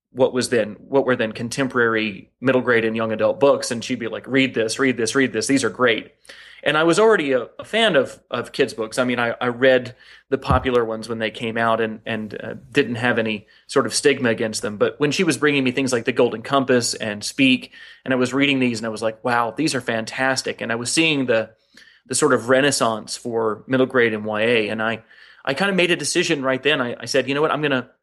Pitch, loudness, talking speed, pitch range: 125 Hz, -20 LUFS, 255 wpm, 115-135 Hz